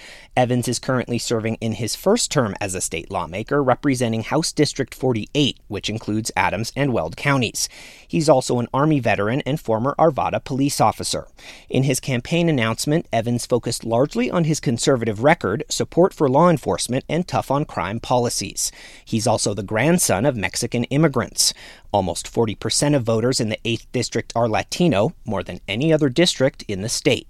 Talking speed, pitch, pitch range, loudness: 170 wpm, 125 Hz, 110-145 Hz, -20 LUFS